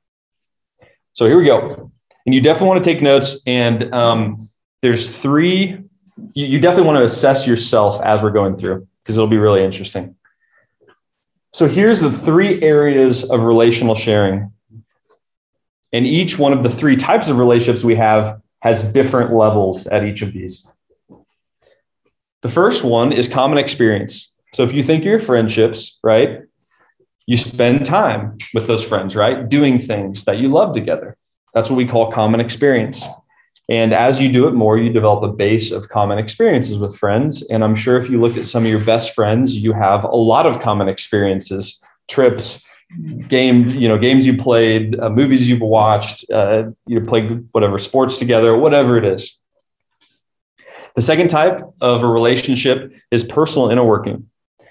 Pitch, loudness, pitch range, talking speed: 120 Hz, -14 LUFS, 110-130 Hz, 170 wpm